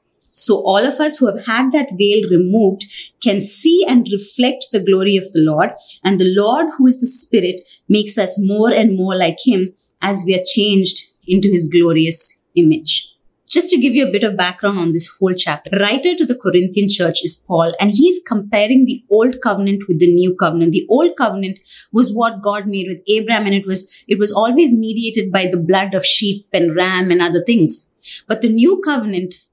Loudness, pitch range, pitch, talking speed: -14 LUFS, 185-230 Hz, 200 Hz, 205 wpm